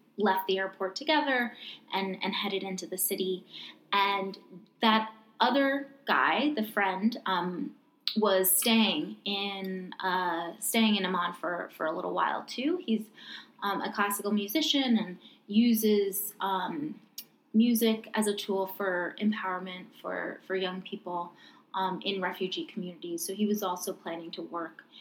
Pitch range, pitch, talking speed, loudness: 185-225 Hz, 200 Hz, 140 wpm, -30 LUFS